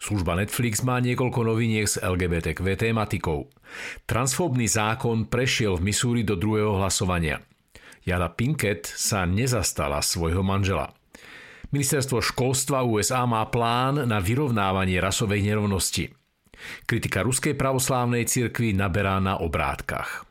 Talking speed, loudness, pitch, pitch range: 110 wpm, -24 LUFS, 110 Hz, 95-125 Hz